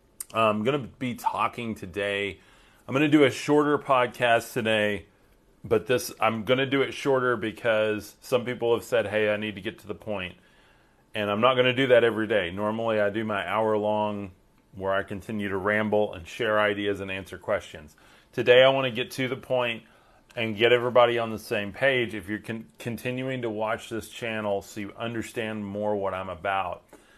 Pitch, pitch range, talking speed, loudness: 110 Hz, 105-125 Hz, 195 wpm, -26 LUFS